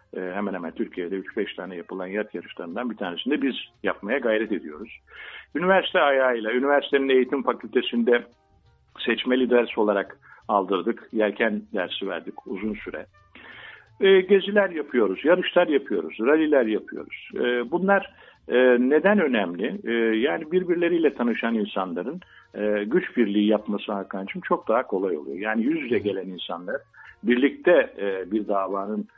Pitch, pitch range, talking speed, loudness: 120 Hz, 105-175 Hz, 130 wpm, -24 LUFS